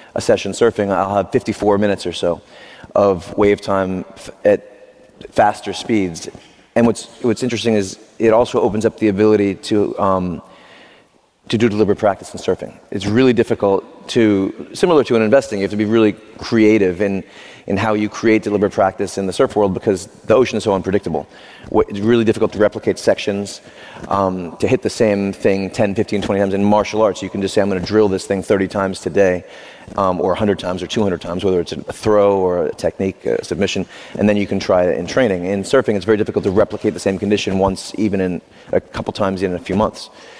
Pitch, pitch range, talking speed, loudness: 100 Hz, 95-110 Hz, 210 wpm, -17 LUFS